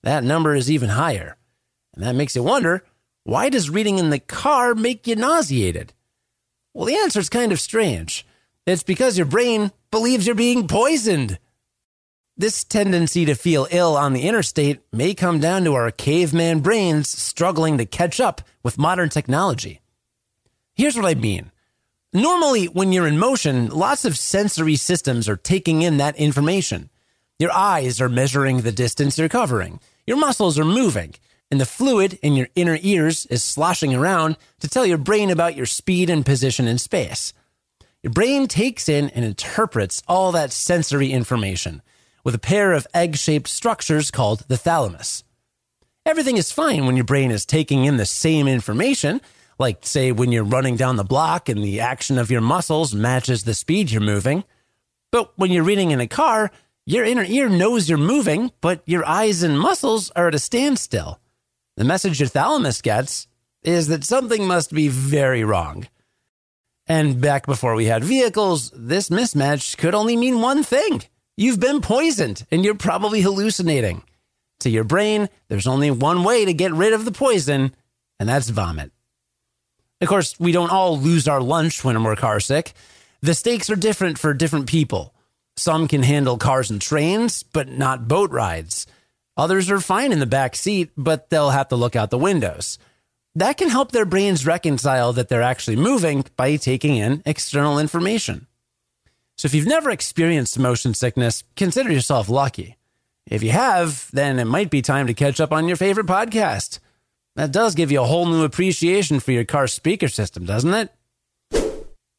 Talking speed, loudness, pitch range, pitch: 175 wpm, -19 LUFS, 125-190 Hz, 155 Hz